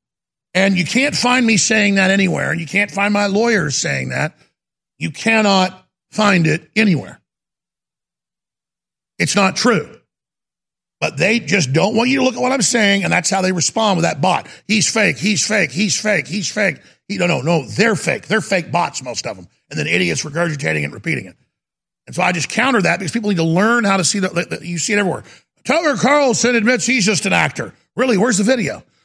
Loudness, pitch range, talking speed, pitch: -16 LUFS, 175-225 Hz, 210 wpm, 200 Hz